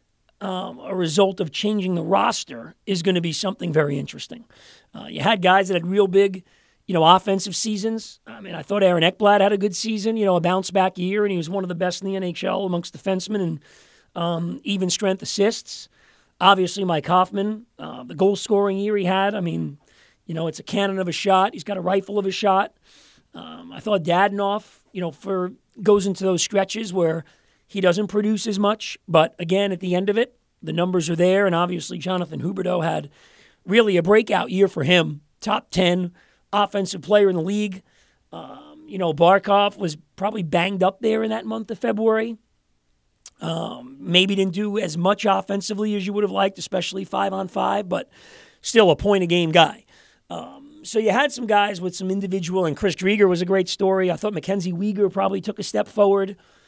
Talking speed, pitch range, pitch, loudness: 205 wpm, 180-205 Hz, 195 Hz, -21 LUFS